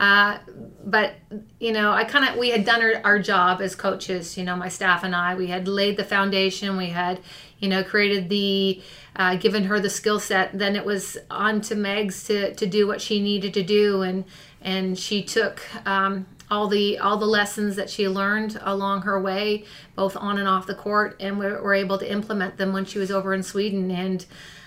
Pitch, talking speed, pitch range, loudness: 200 Hz, 215 wpm, 190-205 Hz, -23 LUFS